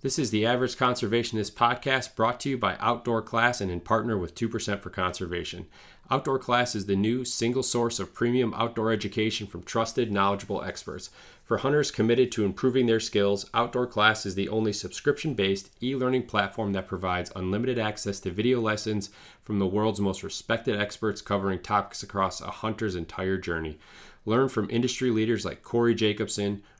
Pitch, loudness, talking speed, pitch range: 110 Hz, -27 LUFS, 175 wpm, 100-120 Hz